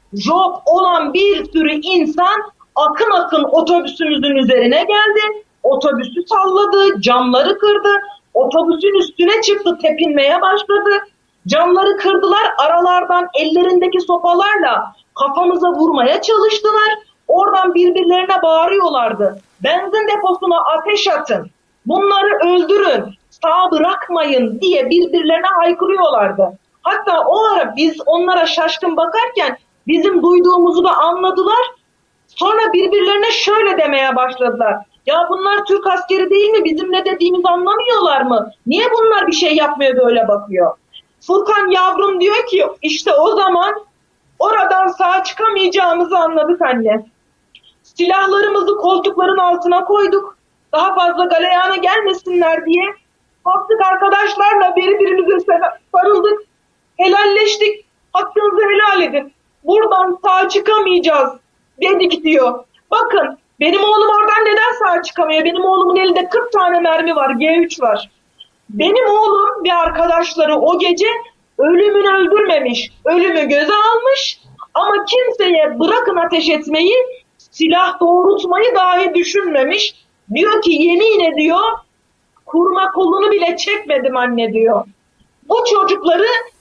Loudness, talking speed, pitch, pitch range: -13 LUFS, 110 wpm, 365 Hz, 325-400 Hz